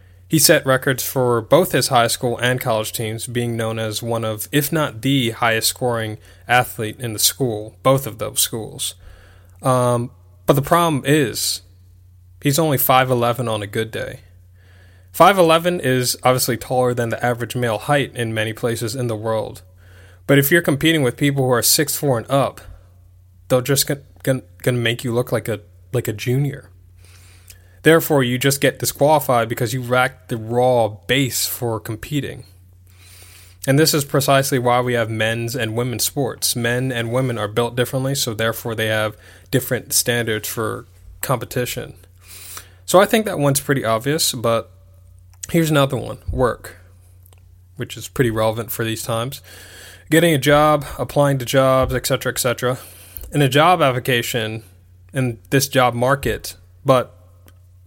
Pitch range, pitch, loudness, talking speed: 95-130 Hz, 120 Hz, -18 LUFS, 160 wpm